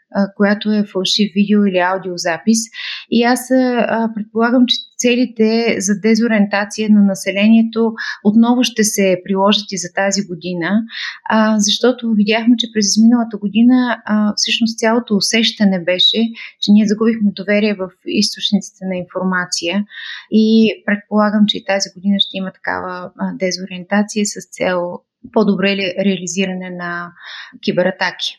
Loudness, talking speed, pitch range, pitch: -15 LUFS, 120 wpm, 190-225 Hz, 210 Hz